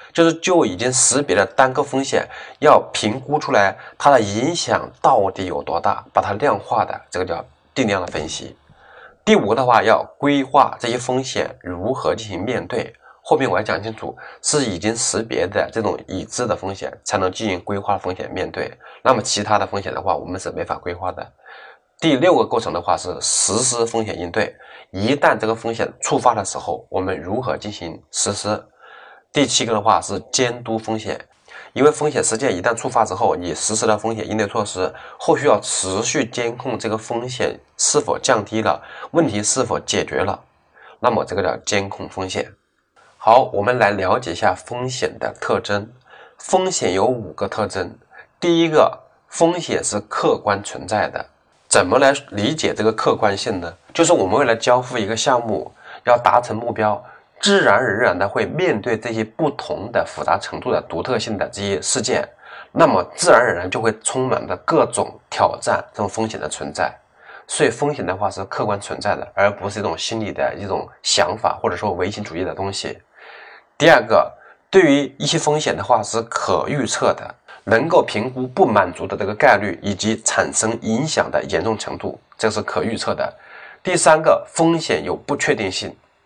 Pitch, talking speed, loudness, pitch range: 115 Hz, 275 characters per minute, -19 LUFS, 105-135 Hz